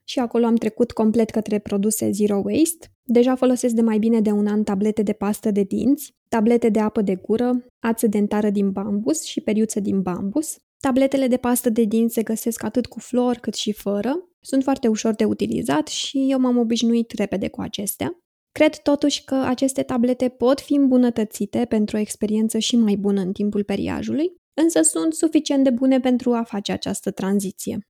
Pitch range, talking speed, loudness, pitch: 215-265 Hz, 185 wpm, -21 LUFS, 235 Hz